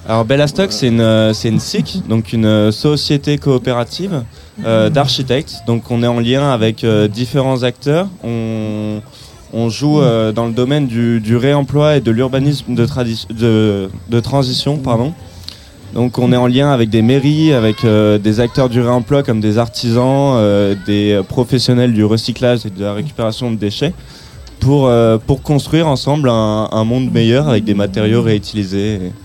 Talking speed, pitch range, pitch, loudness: 165 wpm, 110-135 Hz, 120 Hz, -14 LUFS